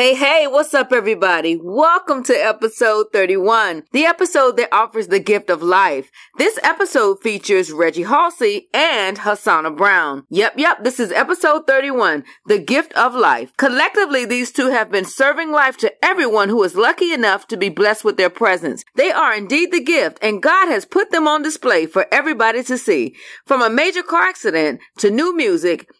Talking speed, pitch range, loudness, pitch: 180 wpm, 210-320 Hz, -15 LUFS, 255 Hz